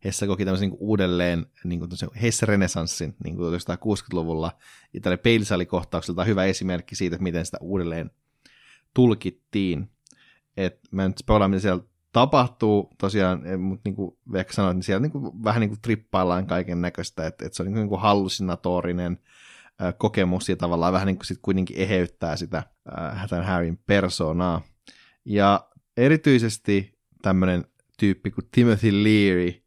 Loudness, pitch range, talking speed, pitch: -24 LUFS, 90-105 Hz, 140 wpm, 95 Hz